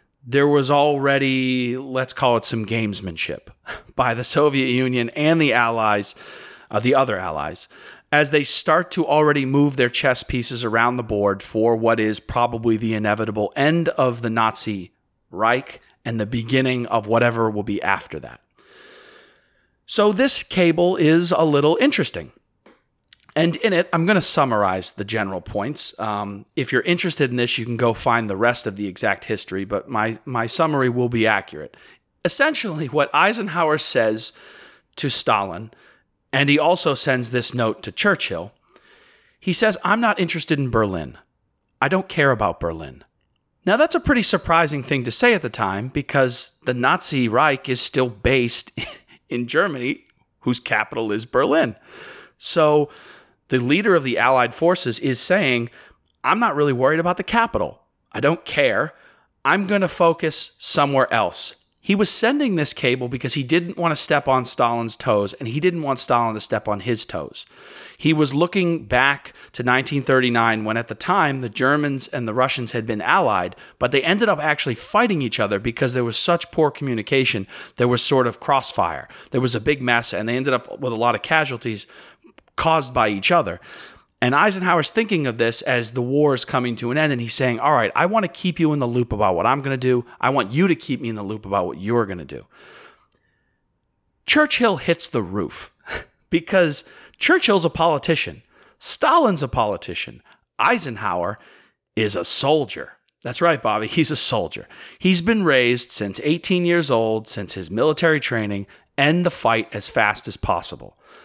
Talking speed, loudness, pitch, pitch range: 180 wpm, -19 LUFS, 130 Hz, 115-165 Hz